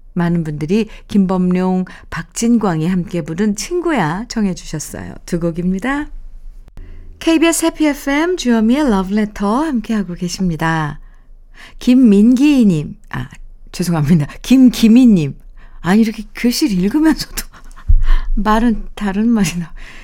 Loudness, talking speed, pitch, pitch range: -15 LUFS, 260 characters per minute, 205 Hz, 175-240 Hz